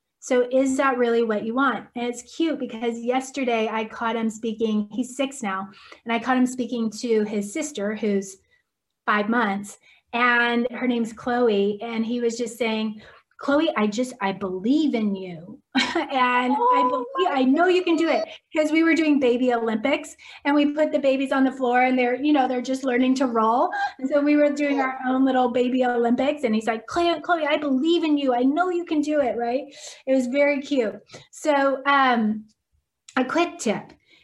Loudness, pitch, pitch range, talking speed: -23 LUFS, 255 Hz, 230-290 Hz, 195 wpm